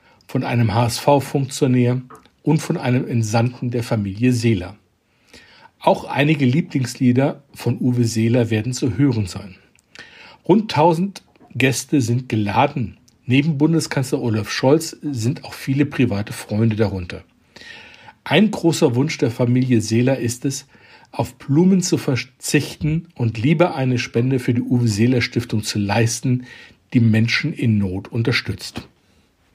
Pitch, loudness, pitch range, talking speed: 125 Hz, -19 LUFS, 115-145 Hz, 130 wpm